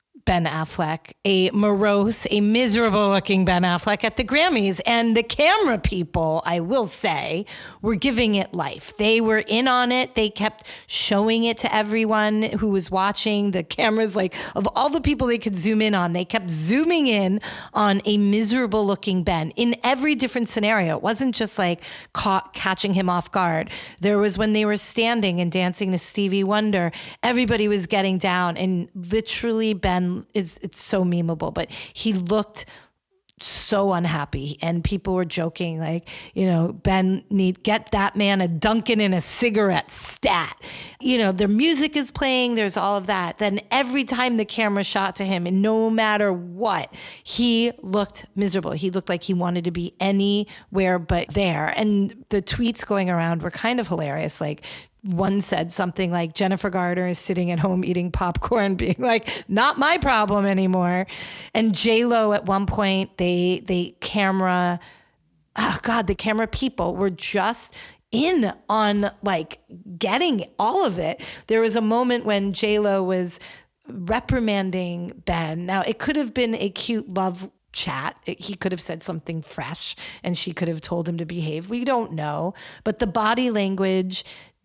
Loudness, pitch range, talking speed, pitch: -22 LUFS, 180-225 Hz, 170 wpm, 200 Hz